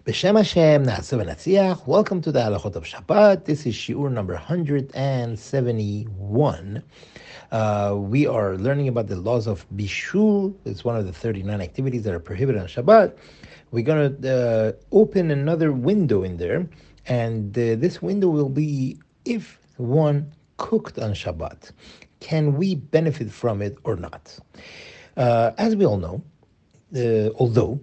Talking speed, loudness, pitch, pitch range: 140 wpm, -22 LUFS, 130 Hz, 110-160 Hz